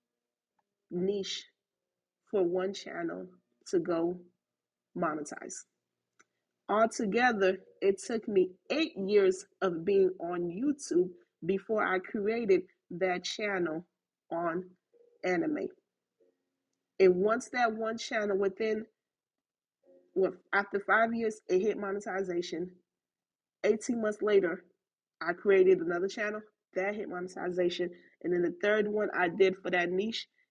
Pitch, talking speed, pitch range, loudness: 195 Hz, 115 wpm, 175-220 Hz, -31 LUFS